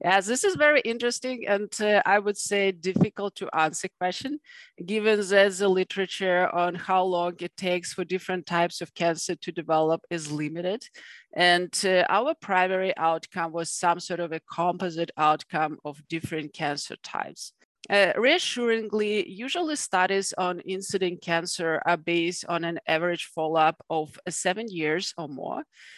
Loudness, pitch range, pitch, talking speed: -26 LUFS, 170-200 Hz, 180 Hz, 150 wpm